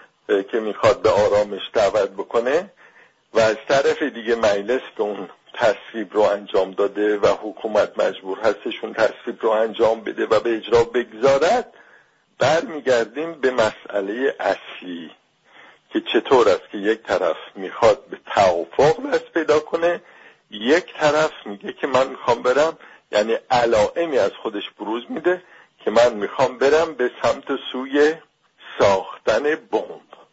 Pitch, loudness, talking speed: 160 Hz, -20 LUFS, 135 wpm